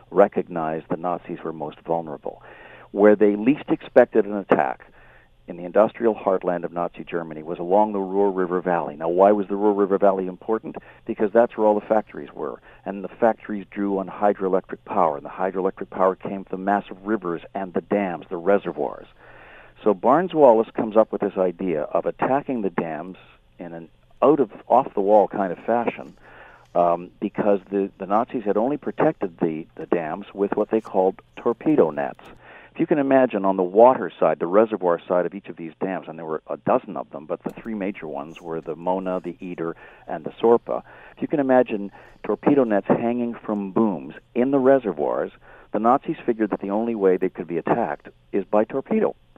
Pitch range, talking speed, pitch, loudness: 90-105 Hz, 195 wpm, 100 Hz, -22 LUFS